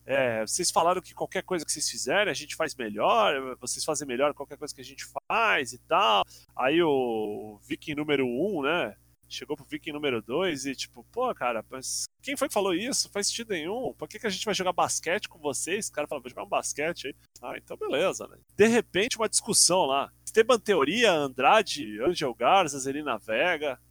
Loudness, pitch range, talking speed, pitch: -27 LUFS, 130-205 Hz, 210 wpm, 150 Hz